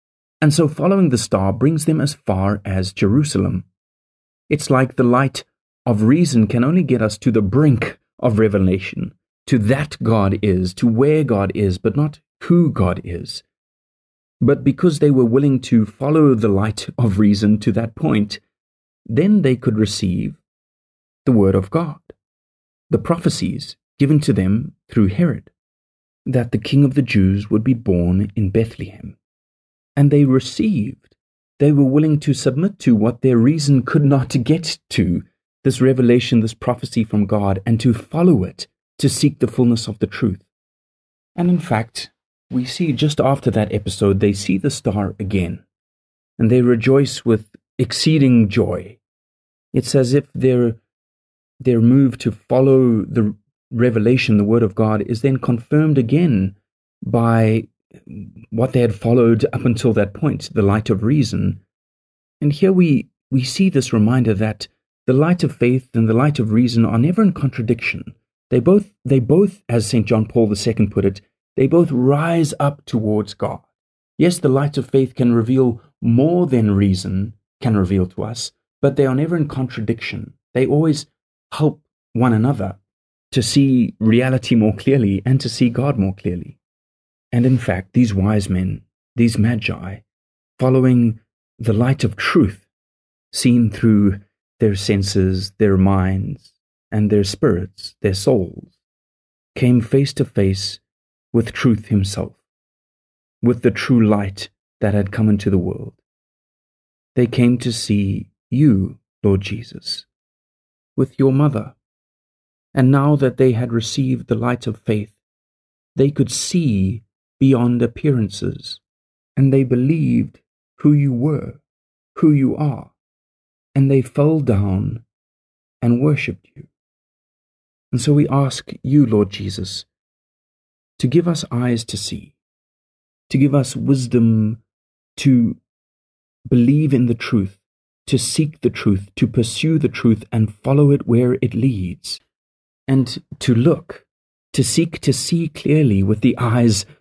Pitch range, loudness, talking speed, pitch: 100-135 Hz, -17 LUFS, 150 wpm, 120 Hz